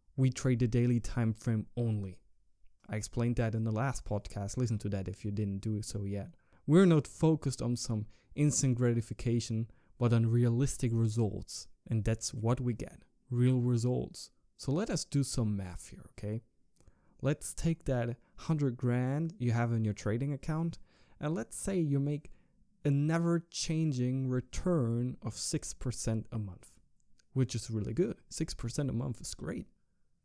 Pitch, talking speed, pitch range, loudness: 120 Hz, 165 wpm, 110-135 Hz, -33 LUFS